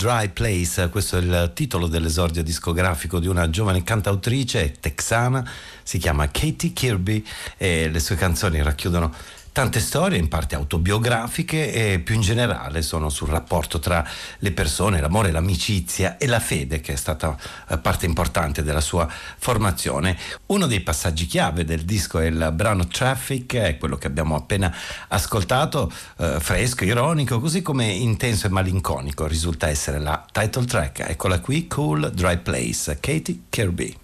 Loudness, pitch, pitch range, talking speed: -22 LUFS, 90 Hz, 80-110 Hz, 150 wpm